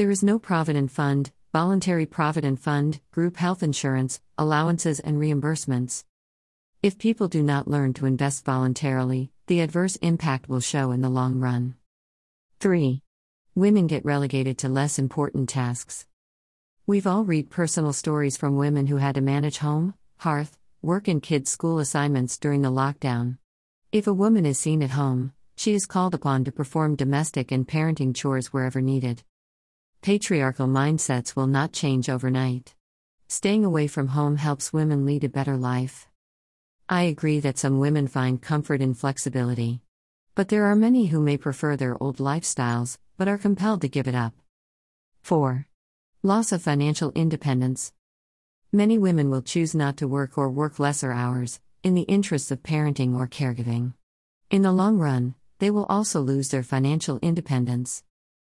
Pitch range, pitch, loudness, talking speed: 130-160 Hz, 140 Hz, -24 LUFS, 160 wpm